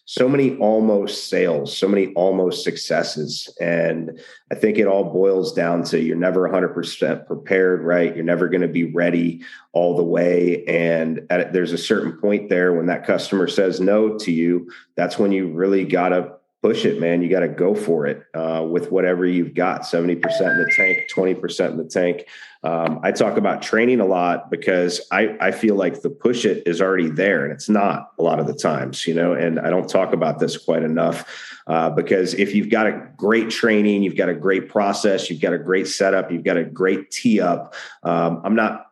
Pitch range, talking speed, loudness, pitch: 85-95 Hz, 210 wpm, -19 LUFS, 90 Hz